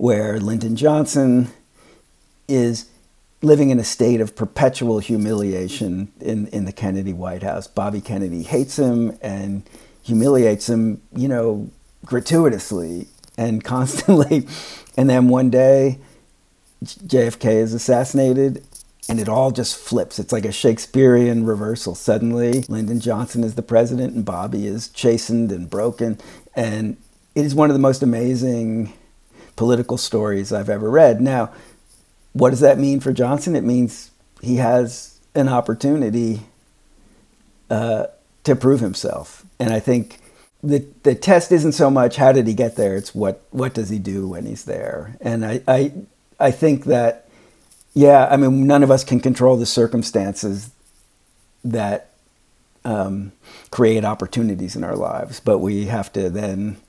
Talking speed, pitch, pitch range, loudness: 145 wpm, 120 Hz, 105-130 Hz, -18 LUFS